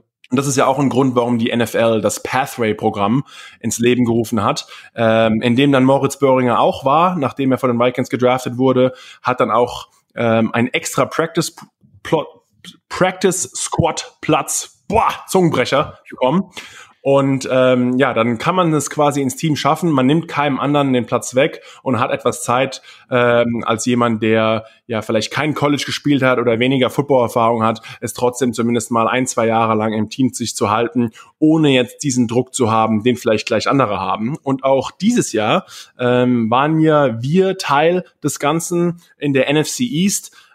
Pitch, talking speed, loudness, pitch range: 125 Hz, 175 wpm, -16 LUFS, 115-145 Hz